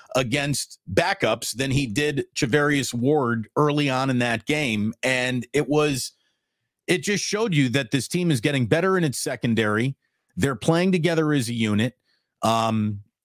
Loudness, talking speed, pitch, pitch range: -23 LUFS, 160 wpm, 140 Hz, 120-150 Hz